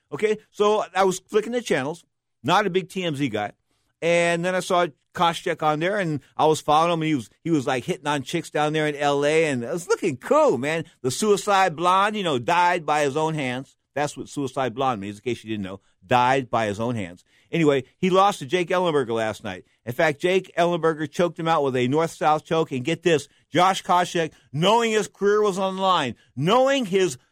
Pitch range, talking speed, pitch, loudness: 130-185 Hz, 220 wpm, 160 Hz, -23 LUFS